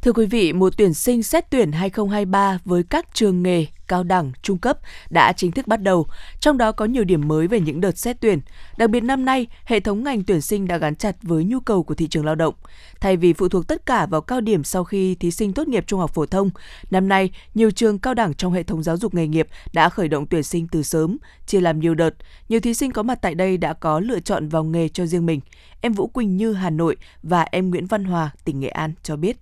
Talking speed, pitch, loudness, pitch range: 260 wpm, 185 Hz, -20 LUFS, 165-220 Hz